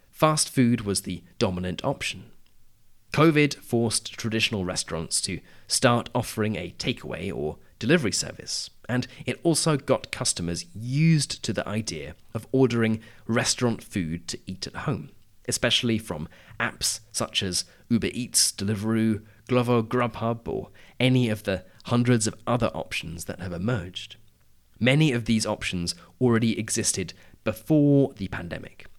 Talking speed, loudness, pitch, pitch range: 135 wpm, -25 LUFS, 110 Hz, 95-125 Hz